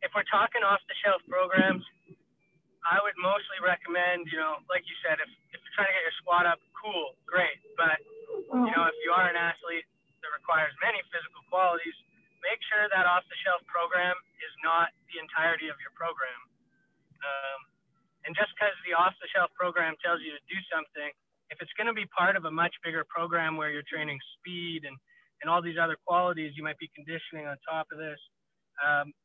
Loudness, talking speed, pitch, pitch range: -29 LUFS, 190 wpm, 170 Hz, 160-185 Hz